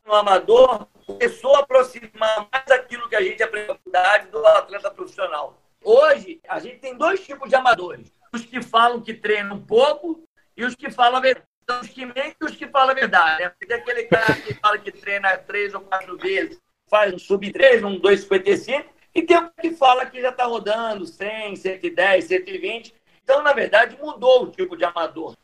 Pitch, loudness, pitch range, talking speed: 255 Hz, -19 LUFS, 215-320 Hz, 185 wpm